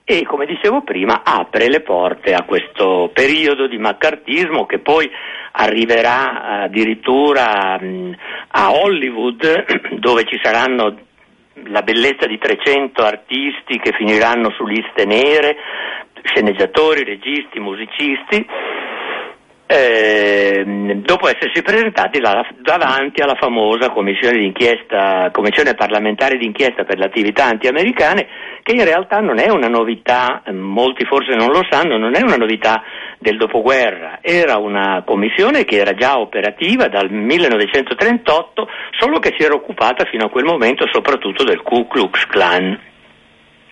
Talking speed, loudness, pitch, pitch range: 125 wpm, -14 LUFS, 115 Hz, 100-135 Hz